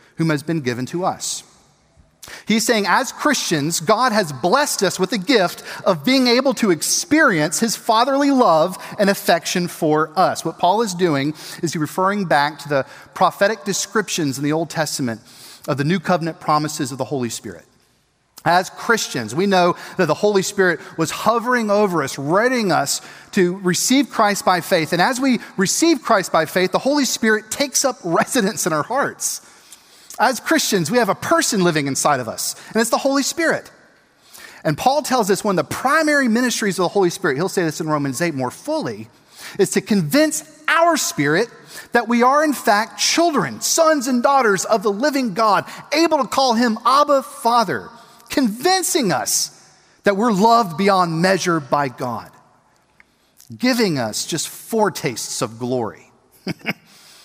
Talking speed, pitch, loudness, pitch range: 170 wpm, 200 Hz, -18 LUFS, 165-250 Hz